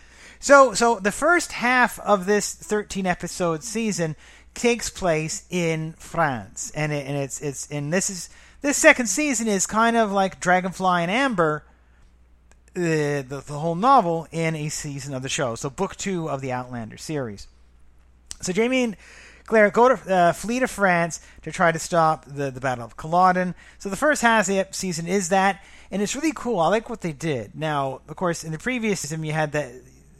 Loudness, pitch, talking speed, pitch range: -22 LUFS, 170 Hz, 190 wpm, 145-210 Hz